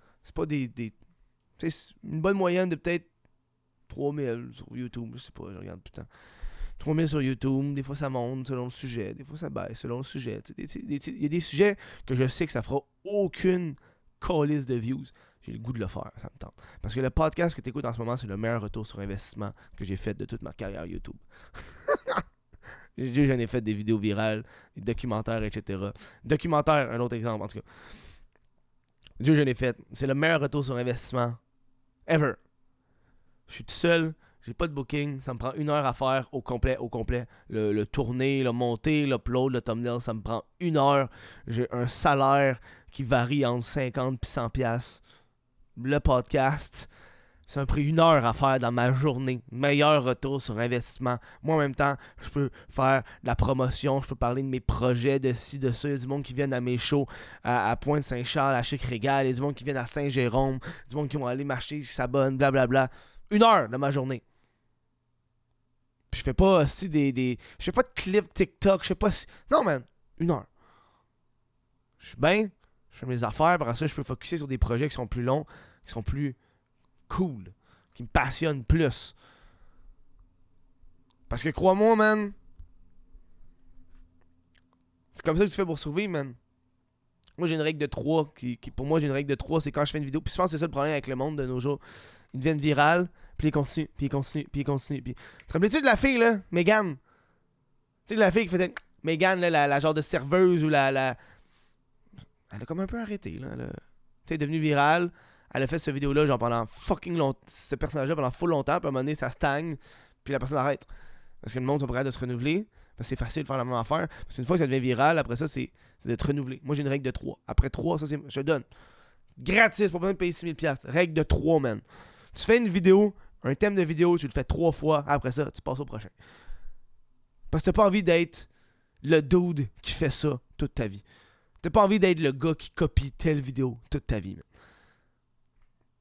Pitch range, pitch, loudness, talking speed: 120-155 Hz, 135 Hz, -27 LUFS, 225 wpm